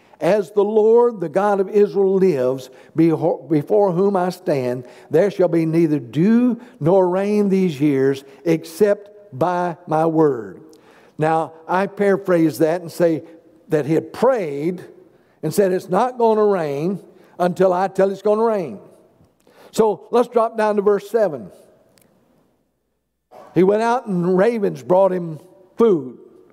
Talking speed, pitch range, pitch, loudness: 145 wpm, 165-205 Hz, 185 Hz, -18 LUFS